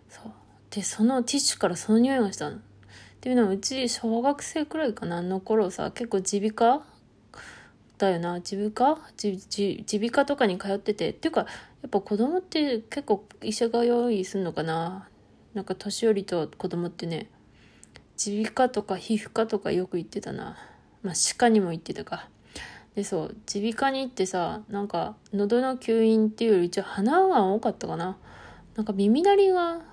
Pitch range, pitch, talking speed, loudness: 195-240 Hz, 215 Hz, 325 characters per minute, -26 LUFS